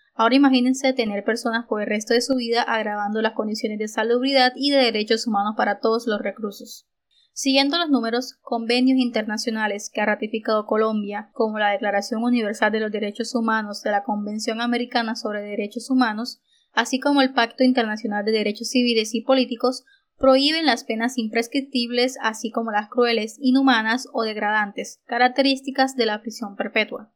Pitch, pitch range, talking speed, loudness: 230 Hz, 215-255 Hz, 160 wpm, -21 LUFS